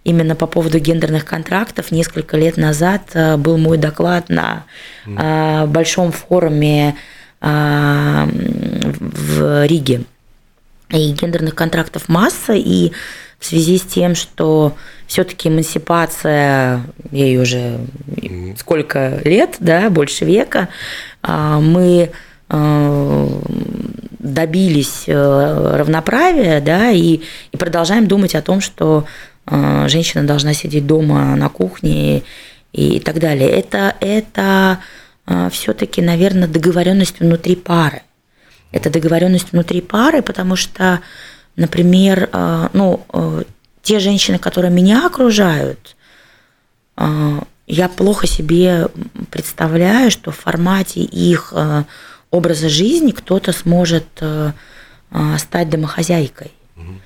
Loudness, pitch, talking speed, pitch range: -14 LUFS, 160 Hz, 95 wpm, 145-180 Hz